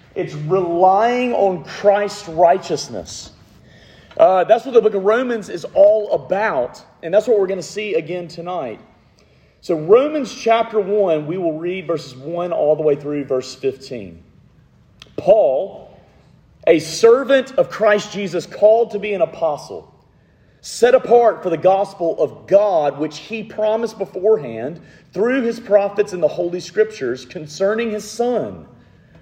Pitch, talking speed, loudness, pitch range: 200 Hz, 145 wpm, -17 LUFS, 170-230 Hz